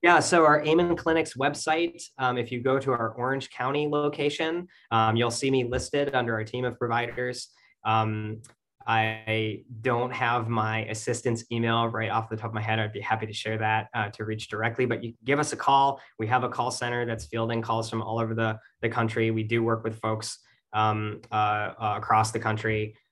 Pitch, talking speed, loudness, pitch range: 115 Hz, 210 wpm, -27 LUFS, 110-130 Hz